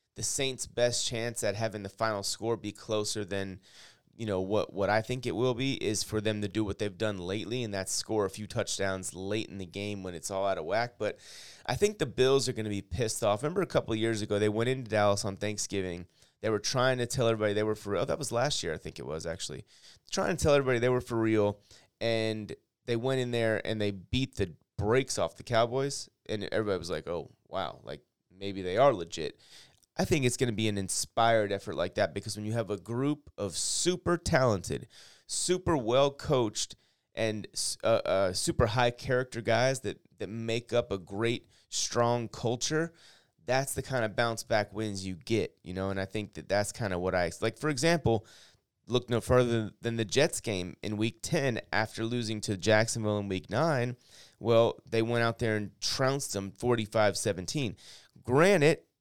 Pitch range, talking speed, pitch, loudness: 100-120 Hz, 215 wpm, 110 Hz, -31 LUFS